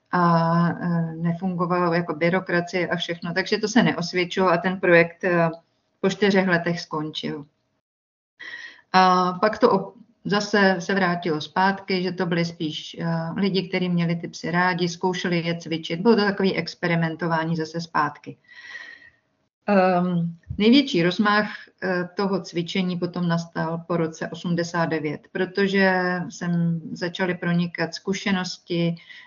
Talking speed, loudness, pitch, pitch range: 120 wpm, -23 LUFS, 180 Hz, 170-190 Hz